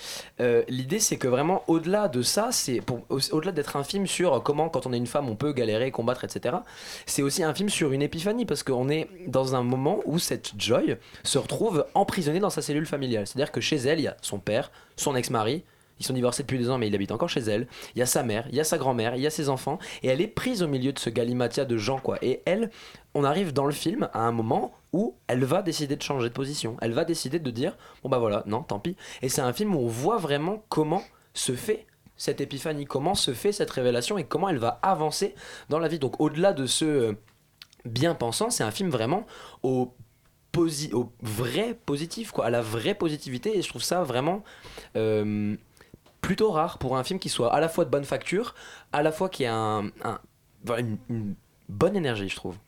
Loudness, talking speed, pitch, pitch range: -27 LUFS, 235 wpm, 140 Hz, 125-165 Hz